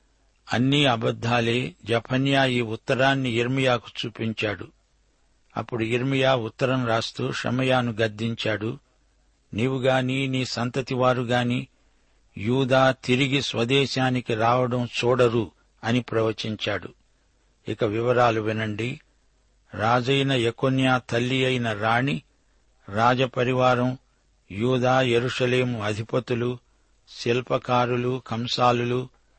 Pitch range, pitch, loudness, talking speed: 115-130 Hz, 125 Hz, -24 LUFS, 75 wpm